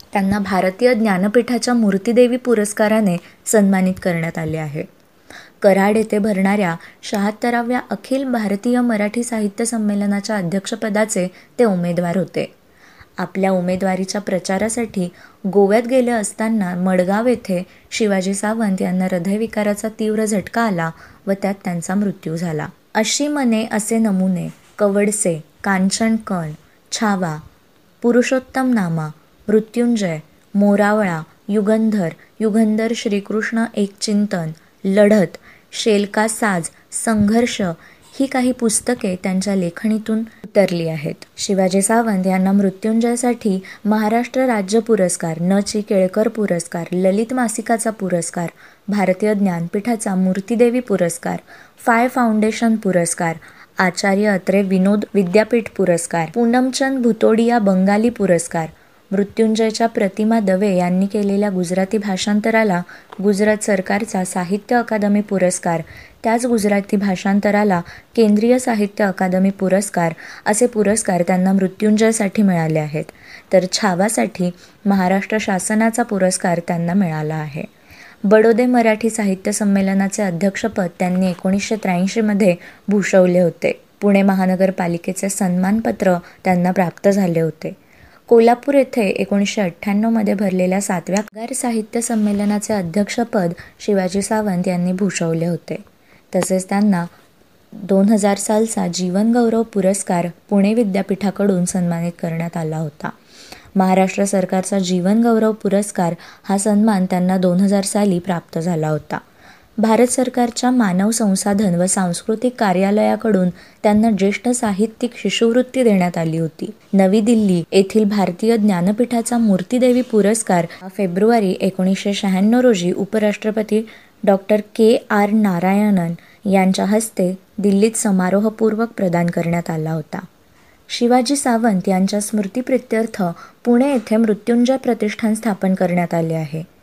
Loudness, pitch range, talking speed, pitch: -17 LUFS, 185-220 Hz, 105 wpm, 205 Hz